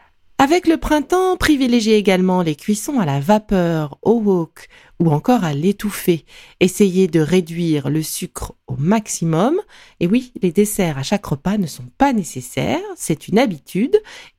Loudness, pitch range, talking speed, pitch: -18 LUFS, 165-250 Hz, 155 wpm, 195 Hz